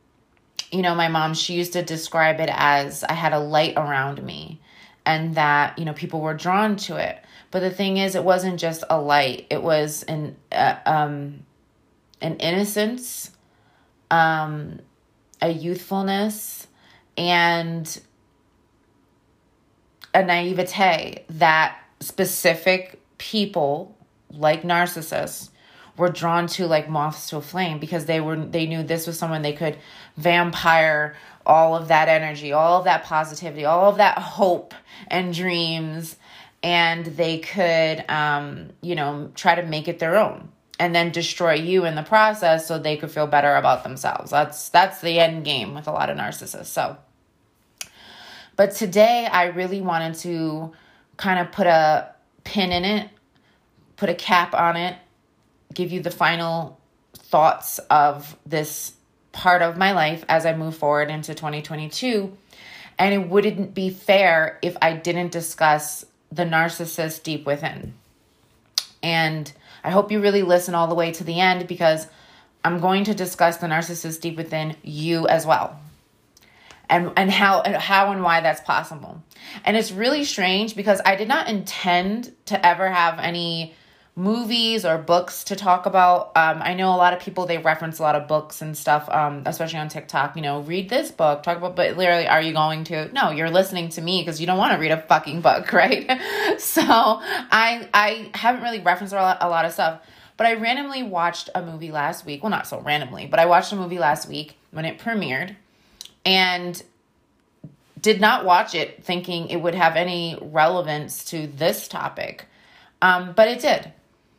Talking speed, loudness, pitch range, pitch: 165 wpm, -21 LUFS, 155-185 Hz, 170 Hz